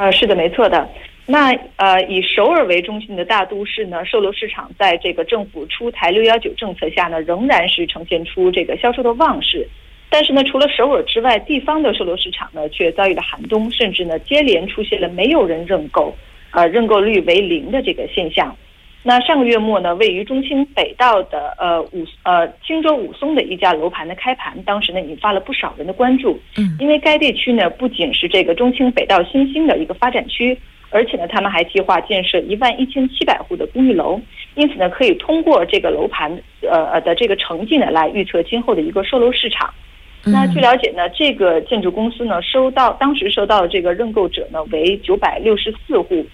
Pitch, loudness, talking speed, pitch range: 235 Hz, -16 LUFS, 315 characters per minute, 185-275 Hz